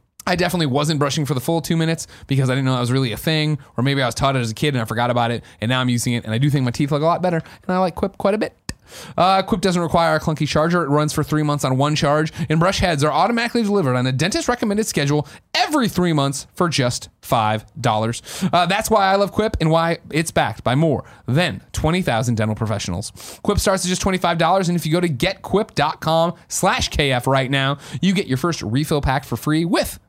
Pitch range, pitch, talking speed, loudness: 130-175 Hz, 150 Hz, 250 wpm, -19 LUFS